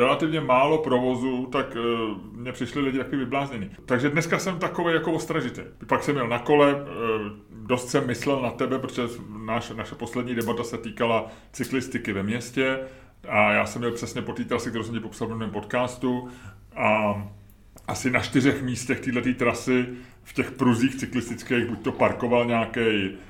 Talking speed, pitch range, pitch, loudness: 175 wpm, 115-130 Hz, 125 Hz, -25 LUFS